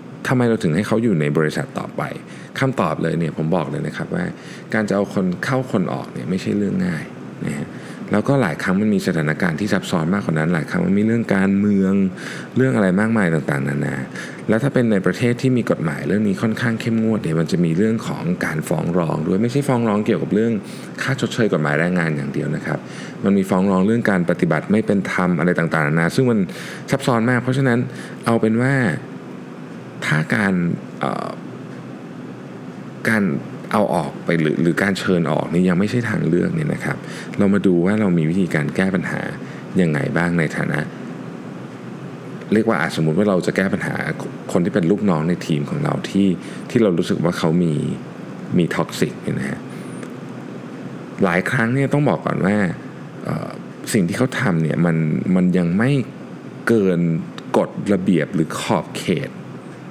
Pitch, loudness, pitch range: 100 Hz, -19 LUFS, 85-120 Hz